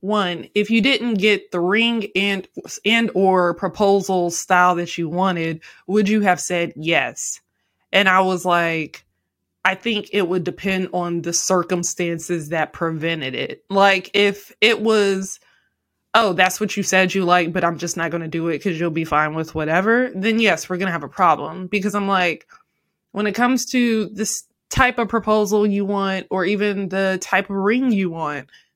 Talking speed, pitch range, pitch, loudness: 185 wpm, 175-210 Hz, 190 Hz, -19 LUFS